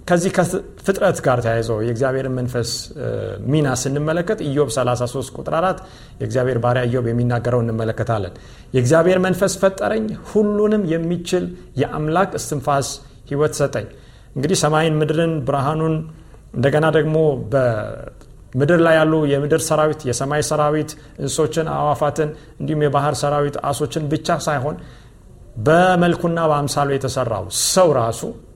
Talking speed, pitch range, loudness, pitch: 110 wpm, 130-160 Hz, -19 LUFS, 150 Hz